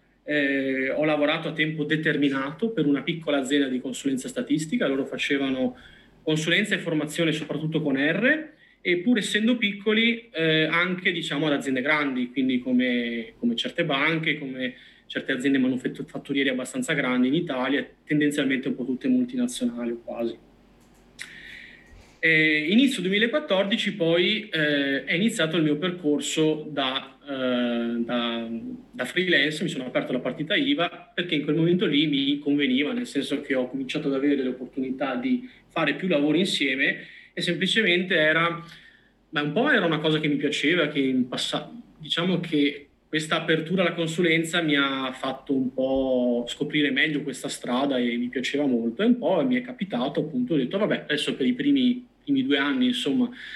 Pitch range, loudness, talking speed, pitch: 135-200 Hz, -24 LUFS, 160 wpm, 155 Hz